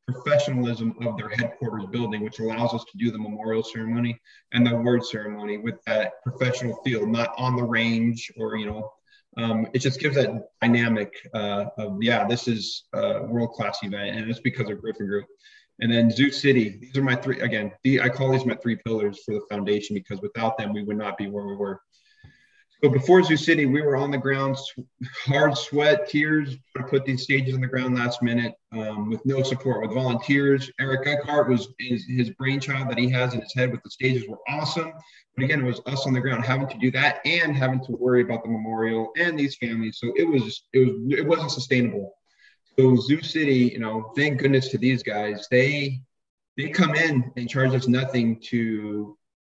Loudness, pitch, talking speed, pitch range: -24 LUFS, 125 Hz, 205 wpm, 115-135 Hz